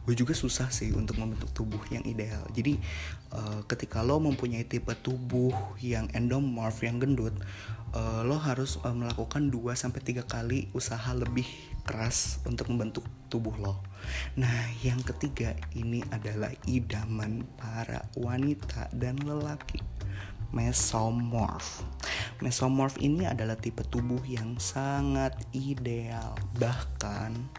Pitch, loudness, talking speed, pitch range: 115 Hz, -32 LUFS, 110 wpm, 105-125 Hz